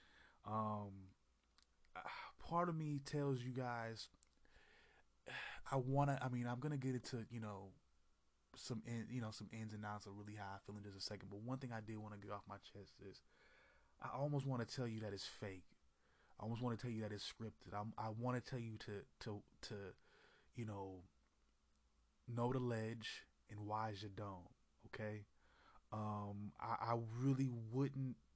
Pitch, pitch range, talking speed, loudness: 110 Hz, 100-125 Hz, 185 wpm, -47 LUFS